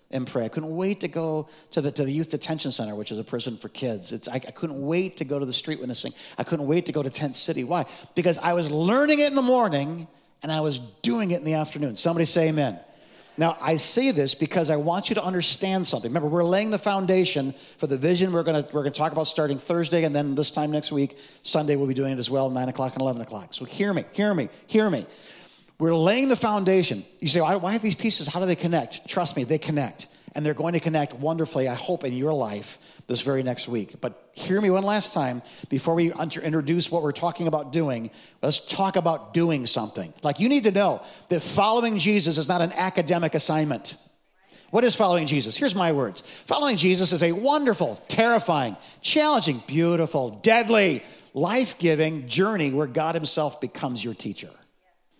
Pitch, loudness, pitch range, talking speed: 160 Hz, -24 LUFS, 140-180 Hz, 220 wpm